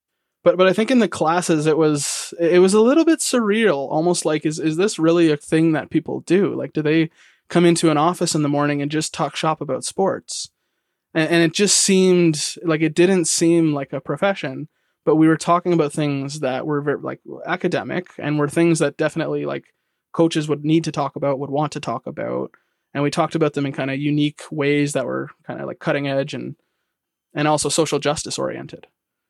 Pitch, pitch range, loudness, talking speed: 155 Hz, 145-170 Hz, -19 LUFS, 215 wpm